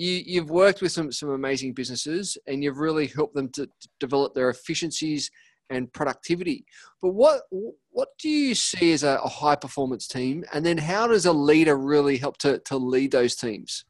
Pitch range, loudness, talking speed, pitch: 135-175 Hz, -24 LUFS, 180 wpm, 150 Hz